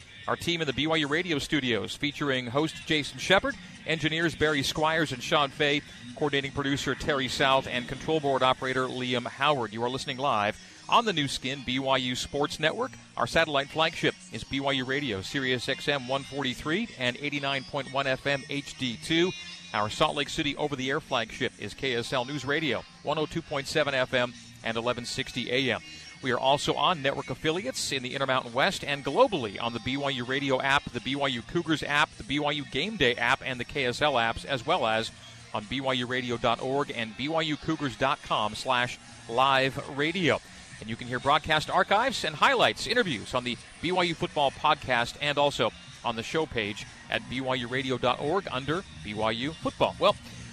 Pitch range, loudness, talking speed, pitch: 125-150 Hz, -28 LUFS, 165 wpm, 135 Hz